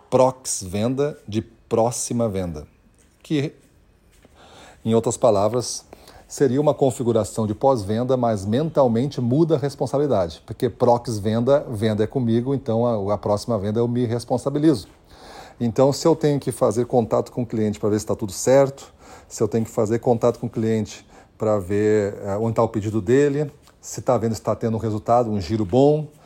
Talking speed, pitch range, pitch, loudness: 170 wpm, 110-130 Hz, 115 Hz, -21 LUFS